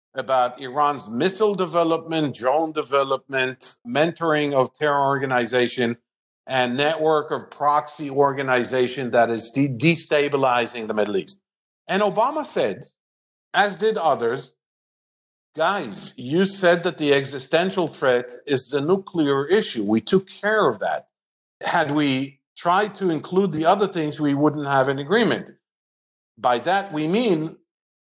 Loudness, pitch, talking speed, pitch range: -22 LUFS, 145 Hz, 130 wpm, 130-175 Hz